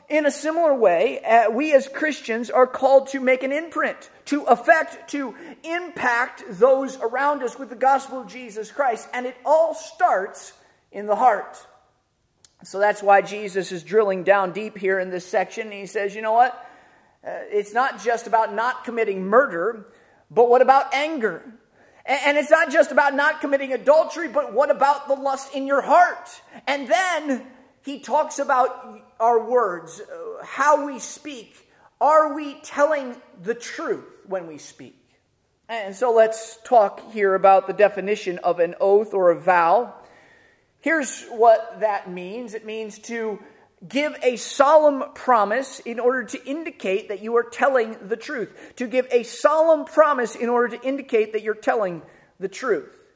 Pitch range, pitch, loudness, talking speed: 220-290 Hz, 255 Hz, -21 LUFS, 165 wpm